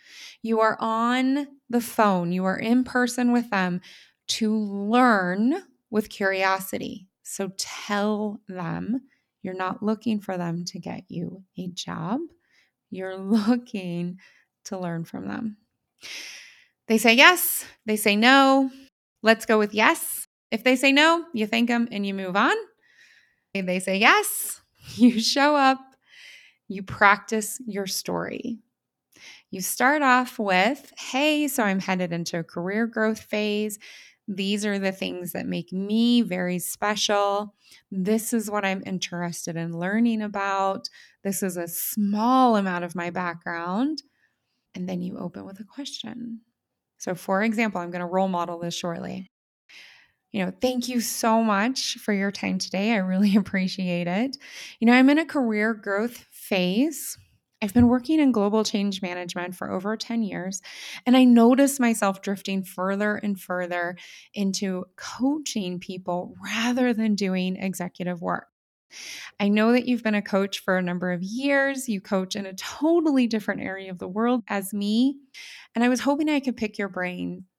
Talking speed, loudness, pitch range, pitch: 155 wpm, -24 LUFS, 190-245 Hz, 210 Hz